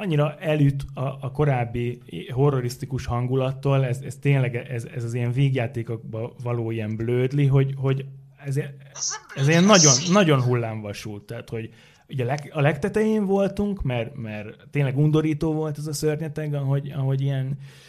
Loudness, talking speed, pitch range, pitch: -23 LUFS, 155 wpm, 120-150 Hz, 135 Hz